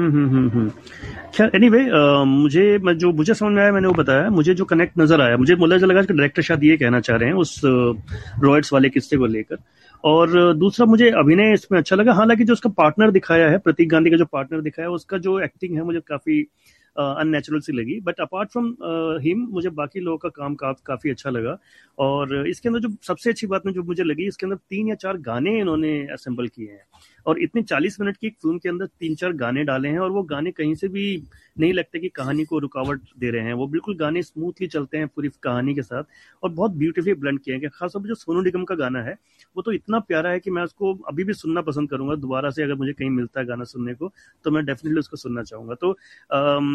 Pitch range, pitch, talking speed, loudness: 140-190 Hz, 165 Hz, 235 wpm, -20 LUFS